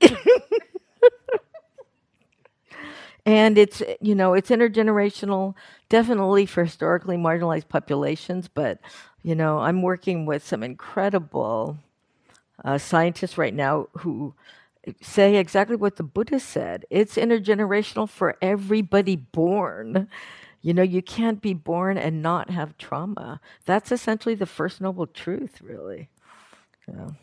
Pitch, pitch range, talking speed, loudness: 190 Hz, 170-215 Hz, 115 wpm, -22 LUFS